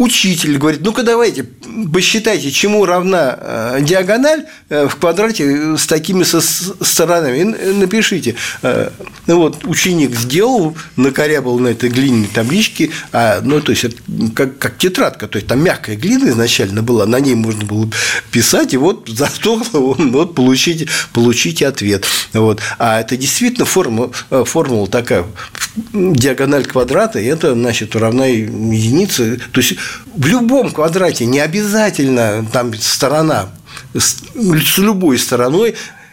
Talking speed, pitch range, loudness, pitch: 130 wpm, 120-185 Hz, -13 LUFS, 145 Hz